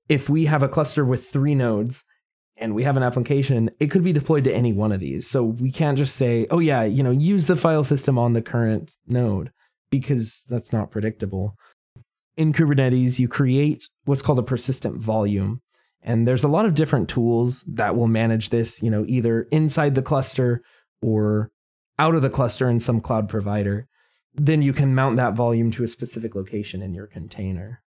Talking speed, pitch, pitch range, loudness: 195 wpm, 125 Hz, 115-140 Hz, -21 LUFS